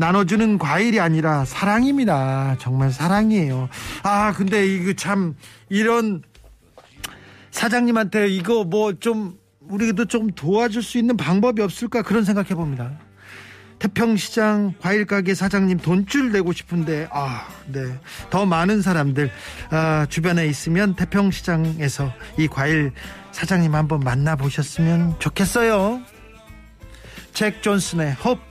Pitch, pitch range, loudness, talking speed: 180 Hz, 140-210 Hz, -20 LUFS, 265 characters per minute